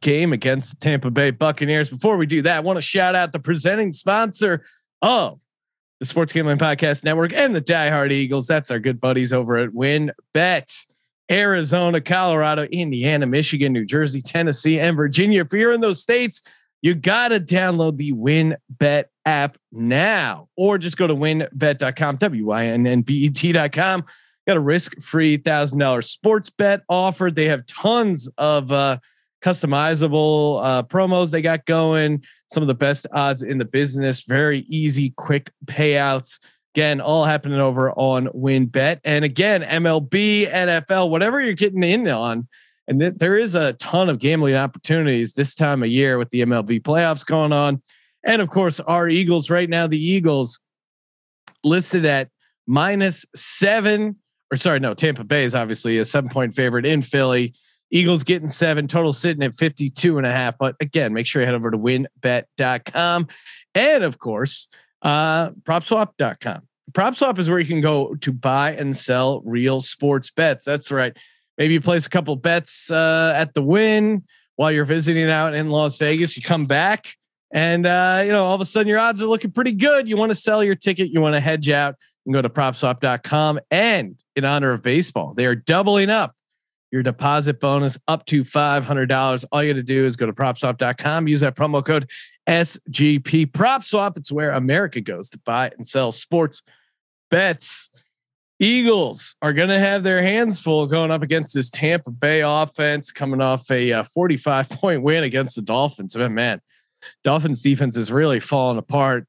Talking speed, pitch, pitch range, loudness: 175 wpm, 150 Hz, 135-170 Hz, -19 LUFS